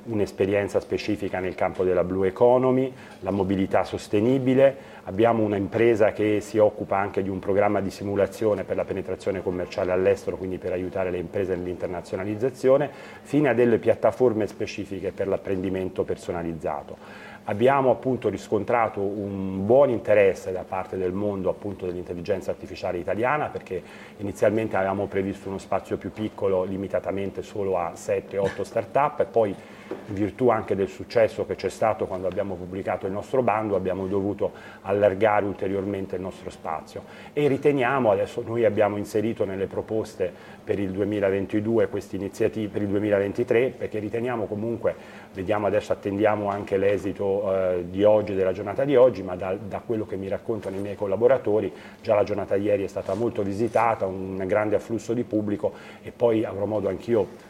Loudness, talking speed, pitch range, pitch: -25 LUFS, 155 wpm, 95-115 Hz, 100 Hz